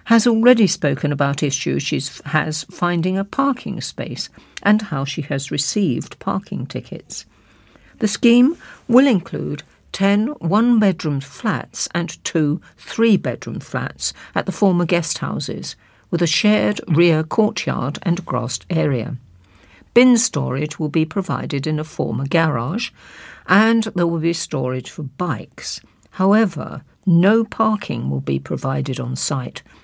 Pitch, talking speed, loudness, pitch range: 170 Hz, 135 wpm, -19 LUFS, 145-210 Hz